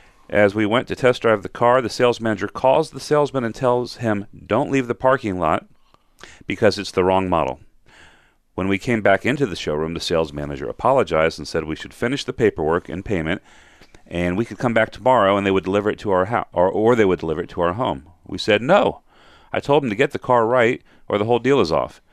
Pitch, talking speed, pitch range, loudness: 105 Hz, 235 wpm, 90-120 Hz, -20 LUFS